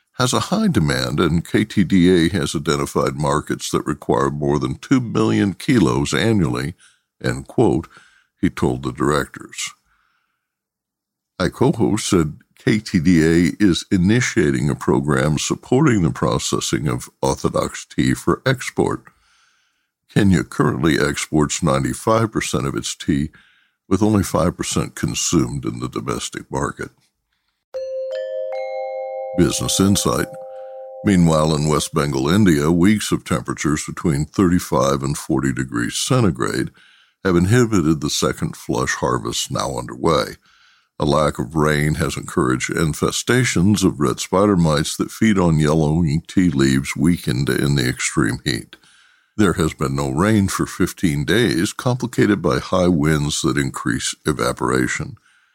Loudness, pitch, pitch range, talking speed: -19 LUFS, 85 Hz, 75-105 Hz, 125 wpm